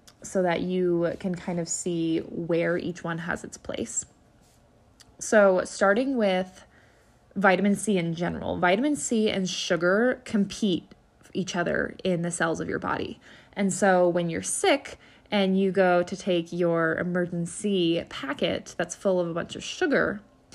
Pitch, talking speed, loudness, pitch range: 180 Hz, 155 wpm, -26 LUFS, 170-195 Hz